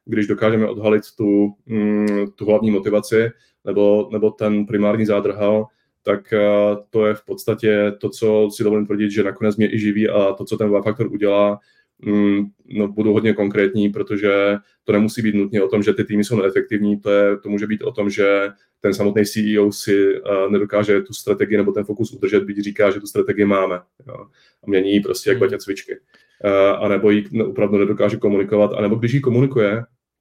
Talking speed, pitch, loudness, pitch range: 185 wpm, 105 Hz, -18 LUFS, 100-110 Hz